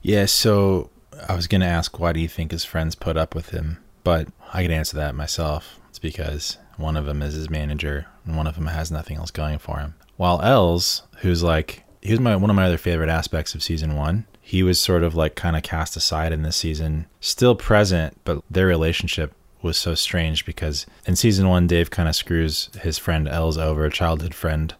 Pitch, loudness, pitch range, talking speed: 80 Hz, -22 LUFS, 80-90 Hz, 225 wpm